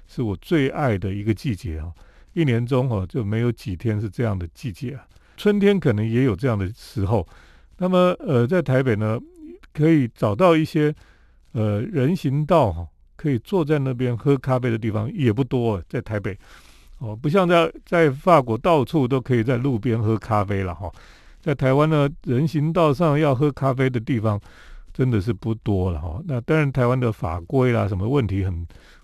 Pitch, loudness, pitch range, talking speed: 125 Hz, -21 LUFS, 105-150 Hz, 265 characters per minute